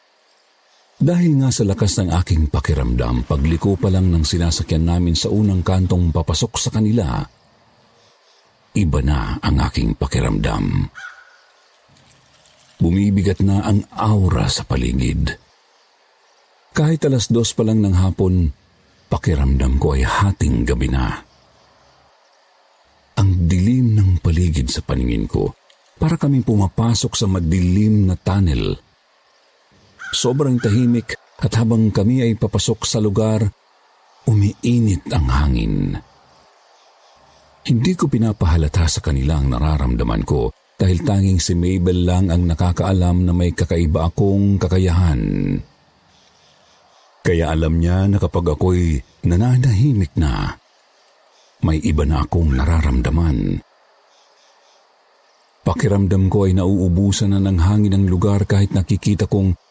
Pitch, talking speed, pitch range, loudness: 95 Hz, 115 wpm, 80-105 Hz, -18 LUFS